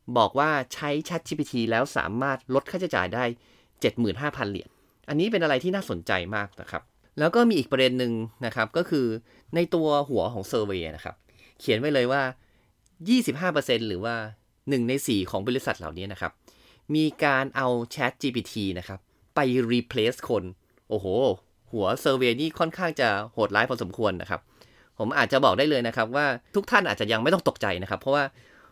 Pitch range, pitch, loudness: 110-145 Hz, 125 Hz, -26 LUFS